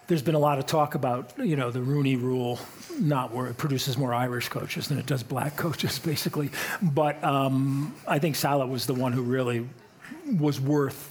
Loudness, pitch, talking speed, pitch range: -27 LUFS, 140 Hz, 200 wpm, 130-150 Hz